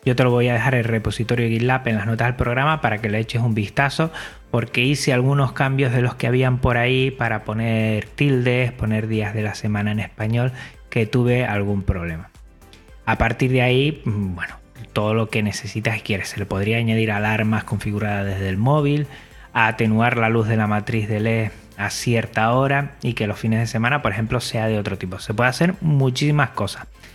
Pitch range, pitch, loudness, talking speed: 105-125 Hz, 115 Hz, -20 LUFS, 205 wpm